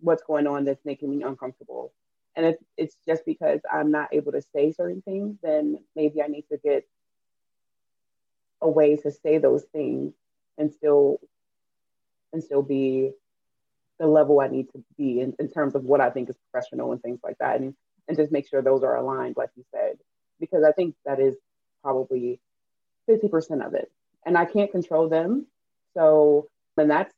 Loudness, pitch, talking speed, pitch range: -24 LUFS, 150 Hz, 185 wpm, 135-160 Hz